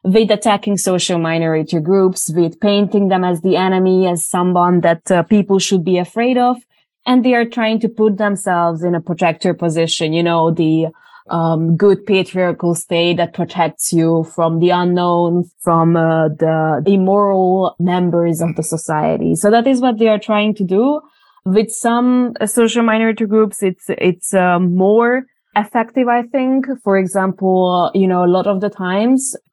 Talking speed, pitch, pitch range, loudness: 165 wpm, 185 Hz, 170-215 Hz, -15 LUFS